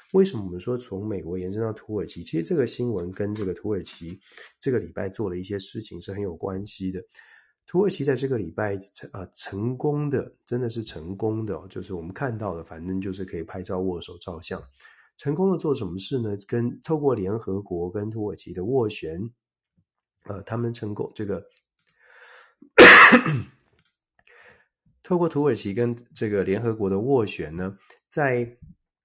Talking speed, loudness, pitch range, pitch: 260 characters per minute, -23 LUFS, 95-120 Hz, 105 Hz